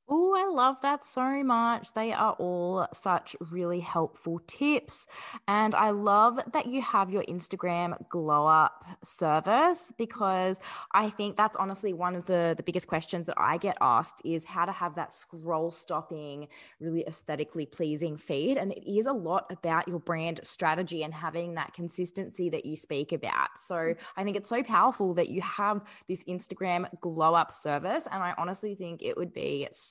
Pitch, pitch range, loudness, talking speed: 180 Hz, 165-205 Hz, -29 LUFS, 180 wpm